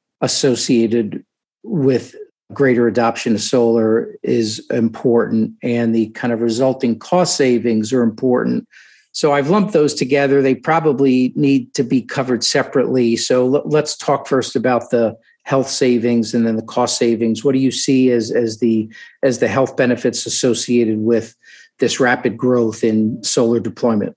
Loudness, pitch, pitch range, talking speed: -16 LUFS, 120 Hz, 115-135 Hz, 150 wpm